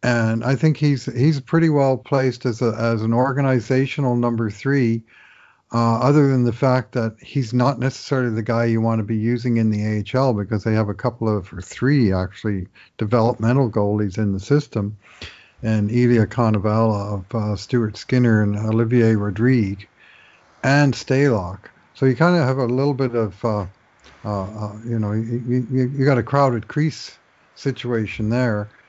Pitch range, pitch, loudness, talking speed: 110-130 Hz, 115 Hz, -20 LUFS, 170 wpm